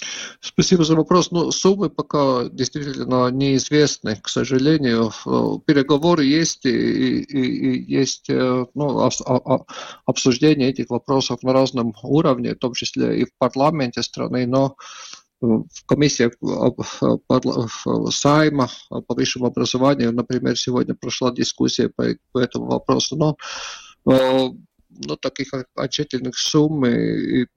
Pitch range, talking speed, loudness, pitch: 125-150 Hz, 120 wpm, -19 LUFS, 130 Hz